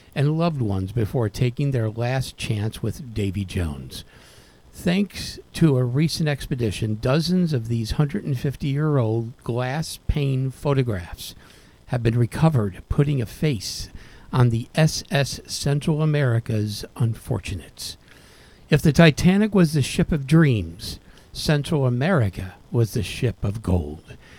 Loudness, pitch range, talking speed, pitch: -23 LUFS, 110-150 Hz, 130 wpm, 125 Hz